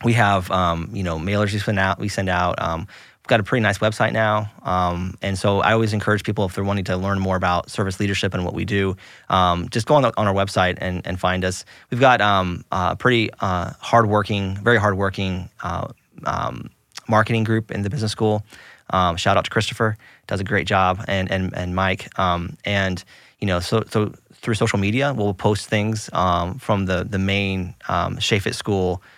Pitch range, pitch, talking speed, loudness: 95-110 Hz, 100 Hz, 210 wpm, -21 LUFS